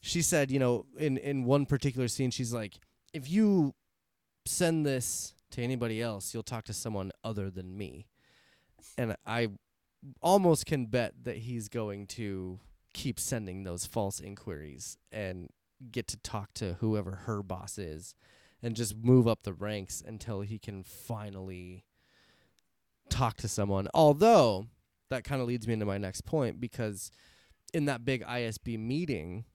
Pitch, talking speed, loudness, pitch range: 110 Hz, 155 wpm, -32 LUFS, 100-125 Hz